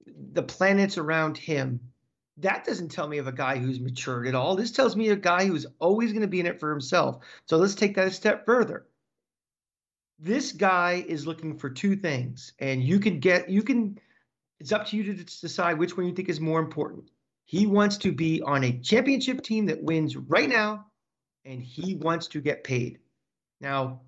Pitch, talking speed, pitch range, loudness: 175 Hz, 200 wpm, 145-205 Hz, -26 LUFS